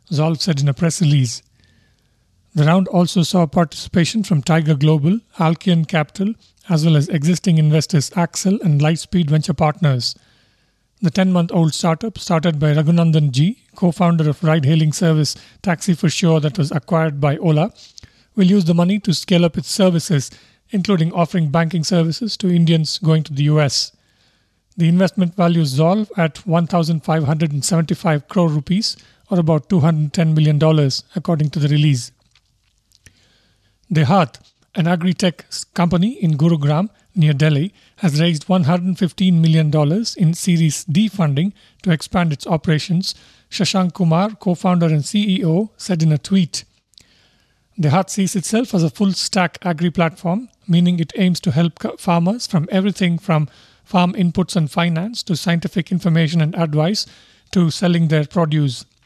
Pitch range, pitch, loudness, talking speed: 155-180 Hz, 165 Hz, -17 LUFS, 150 wpm